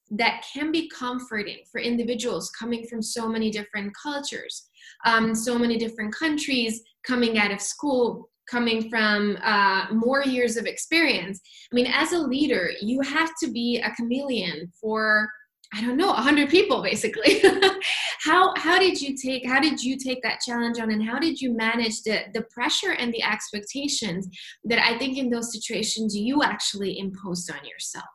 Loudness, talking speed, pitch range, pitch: -24 LUFS, 170 wpm, 220-280 Hz, 235 Hz